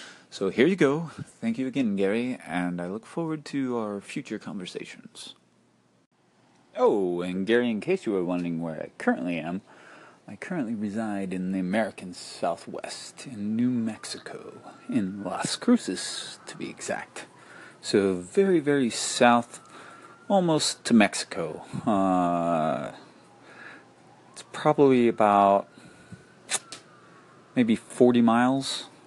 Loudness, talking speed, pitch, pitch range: -26 LUFS, 120 wpm, 115 Hz, 95-140 Hz